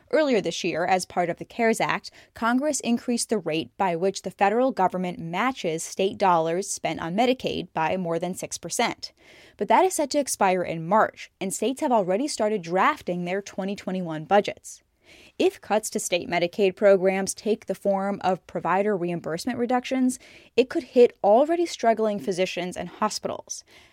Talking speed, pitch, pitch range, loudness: 165 wpm, 200 Hz, 180-235 Hz, -25 LUFS